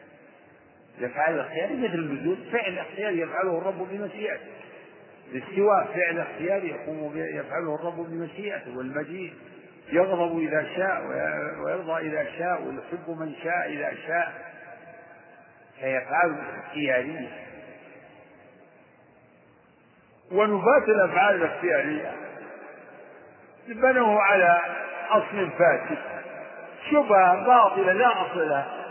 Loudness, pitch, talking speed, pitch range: -25 LUFS, 175 Hz, 85 wpm, 165-200 Hz